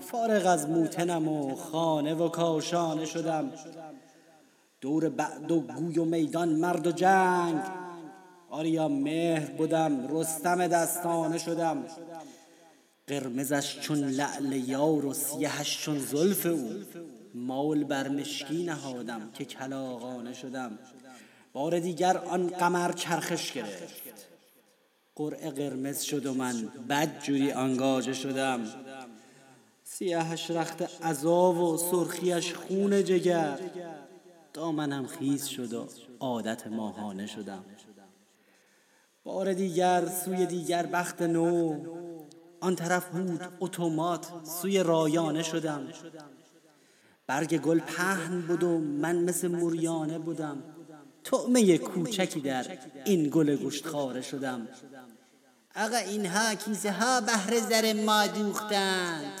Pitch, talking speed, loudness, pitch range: 165 Hz, 110 wpm, -29 LUFS, 145-175 Hz